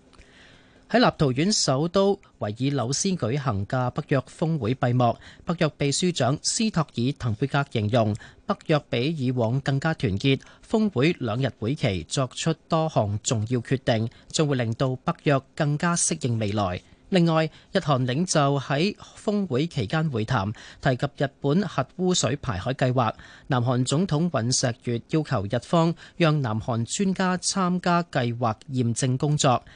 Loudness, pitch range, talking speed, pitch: -25 LUFS, 125-160 Hz, 230 characters per minute, 140 Hz